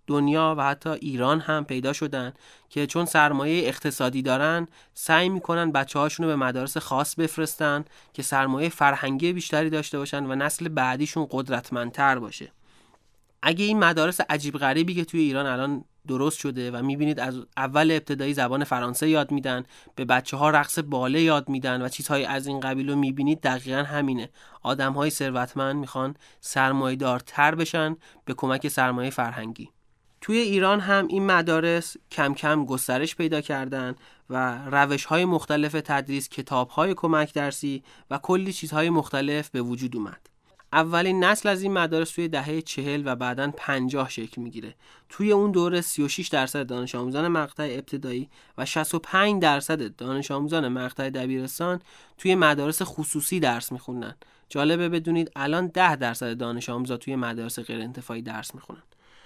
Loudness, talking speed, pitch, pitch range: -25 LUFS, 150 wpm, 145 Hz, 130-160 Hz